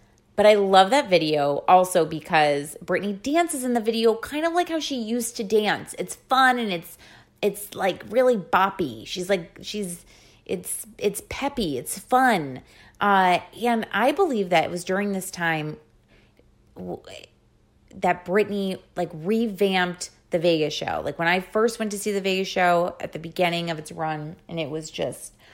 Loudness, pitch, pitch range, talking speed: -23 LUFS, 190 Hz, 175-220 Hz, 170 wpm